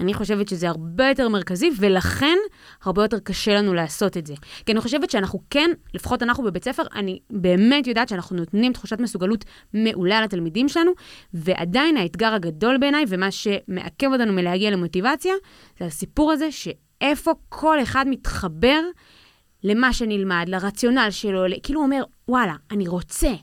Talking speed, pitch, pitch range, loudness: 155 wpm, 215 Hz, 185-265 Hz, -21 LUFS